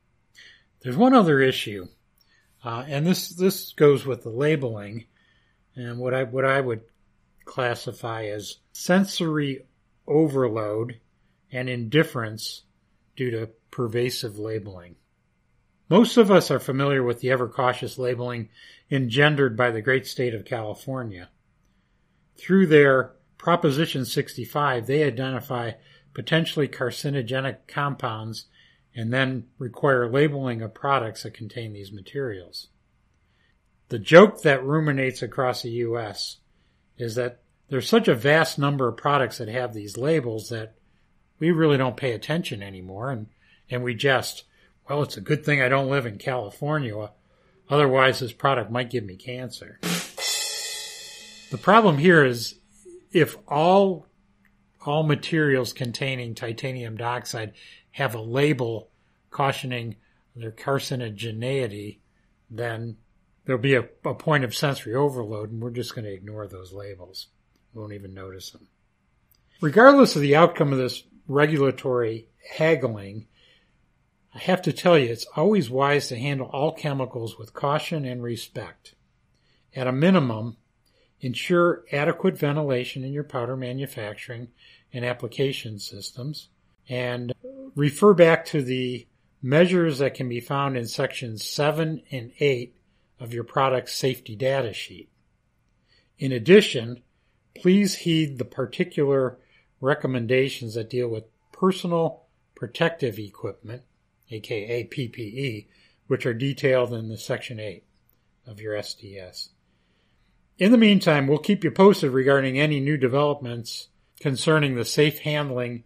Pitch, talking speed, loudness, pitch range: 130 Hz, 130 wpm, -23 LUFS, 115-145 Hz